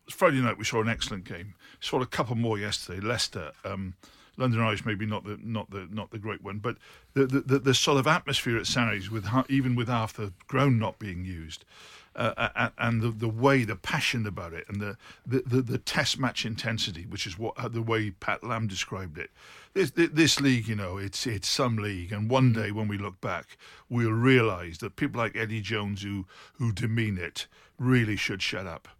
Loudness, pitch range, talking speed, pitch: -28 LUFS, 105-125 Hz, 205 wpm, 115 Hz